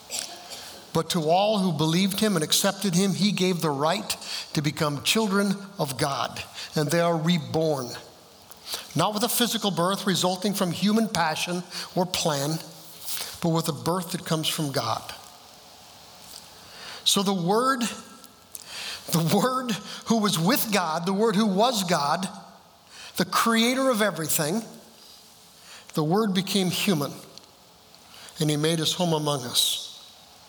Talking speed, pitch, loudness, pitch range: 140 wpm, 185 Hz, -25 LUFS, 160-215 Hz